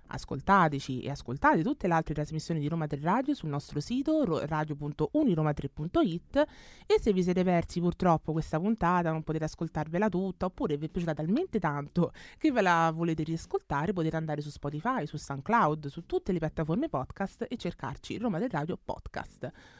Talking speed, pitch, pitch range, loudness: 165 wpm, 165 Hz, 150-185 Hz, -30 LUFS